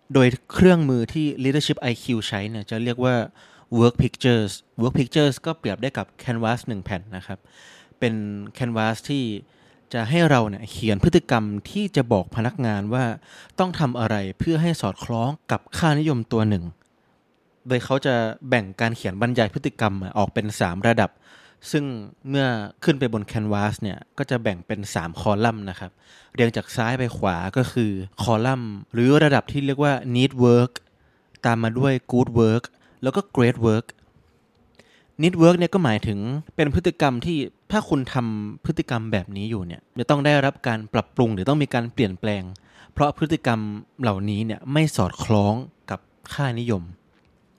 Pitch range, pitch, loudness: 105-140 Hz, 120 Hz, -22 LUFS